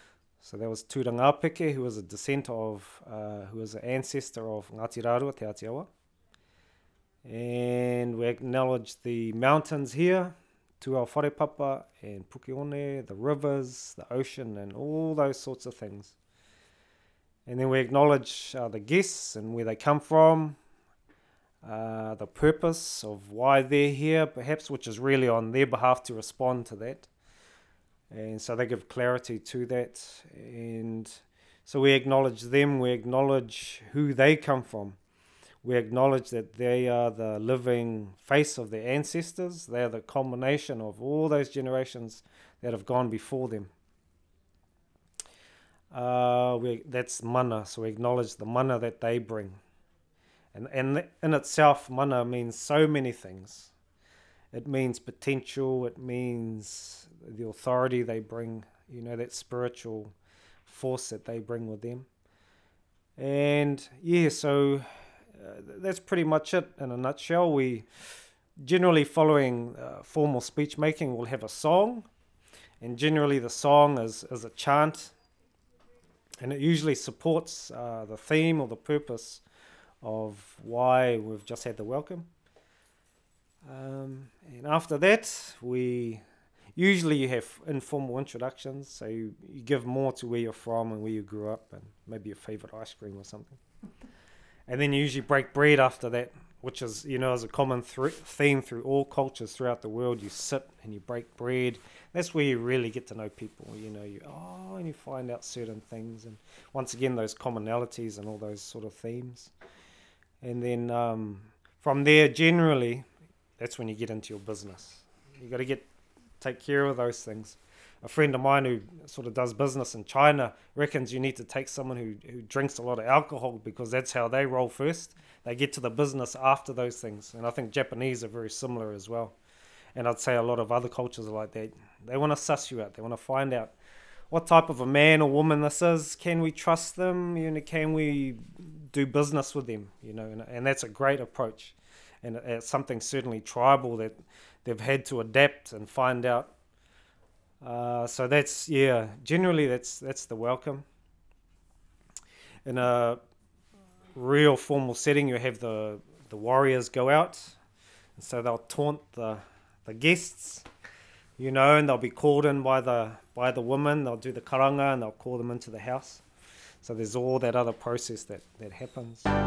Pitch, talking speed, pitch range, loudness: 125 Hz, 170 wpm, 110-140 Hz, -28 LUFS